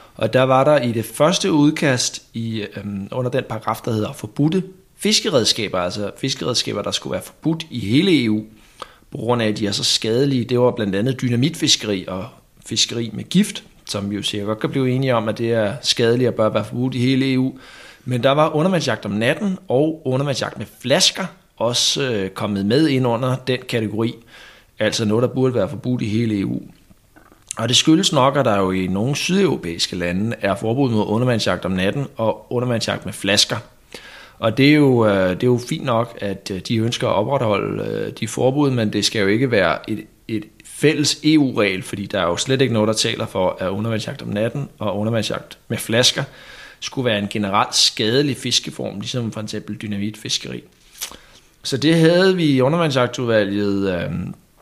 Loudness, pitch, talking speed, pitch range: -19 LUFS, 115 Hz, 185 wpm, 105-135 Hz